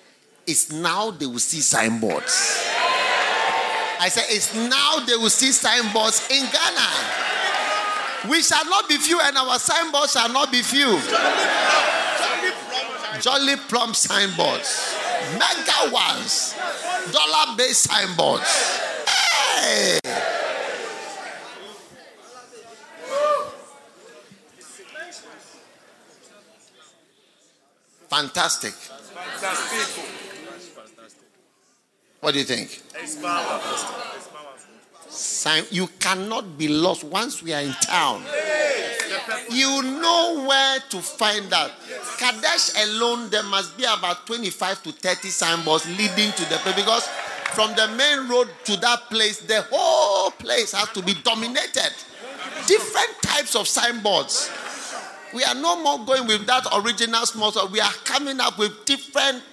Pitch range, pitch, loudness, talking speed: 205-275 Hz, 235 Hz, -20 LUFS, 110 wpm